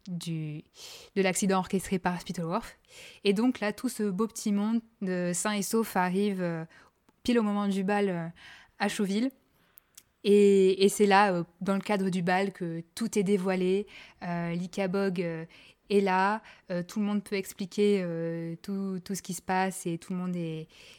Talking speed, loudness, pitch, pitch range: 190 wpm, -29 LUFS, 195 Hz, 180-205 Hz